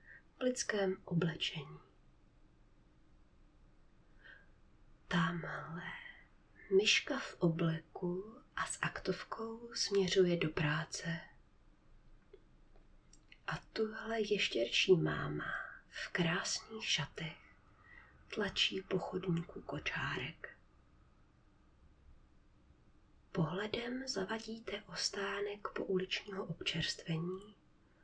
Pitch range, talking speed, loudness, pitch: 170-220 Hz, 60 wpm, -37 LUFS, 190 Hz